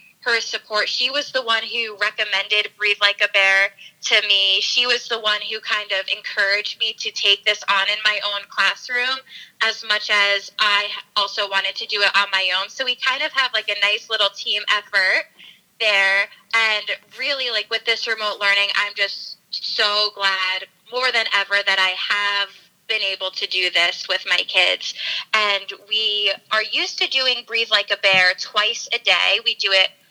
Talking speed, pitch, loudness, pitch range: 190 wpm, 205 Hz, -18 LUFS, 195-225 Hz